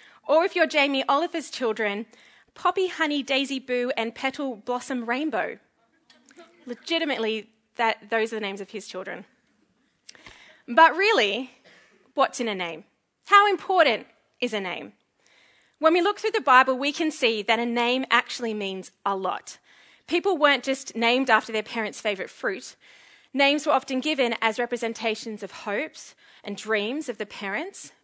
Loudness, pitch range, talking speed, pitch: -24 LUFS, 220-310 Hz, 155 wpm, 250 Hz